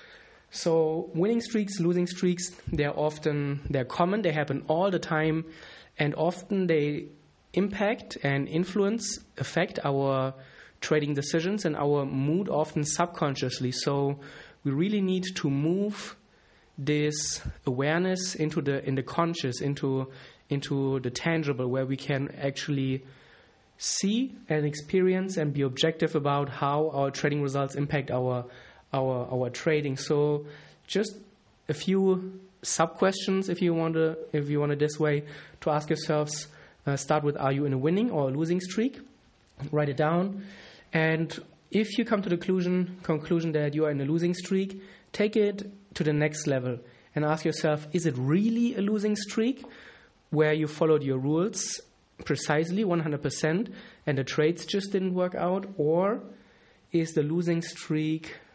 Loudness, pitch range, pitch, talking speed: -28 LUFS, 145-185 Hz, 155 Hz, 155 wpm